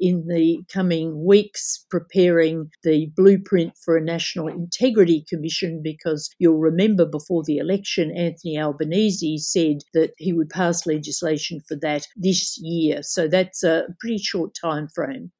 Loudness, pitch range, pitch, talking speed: -21 LUFS, 160-185 Hz, 165 Hz, 145 wpm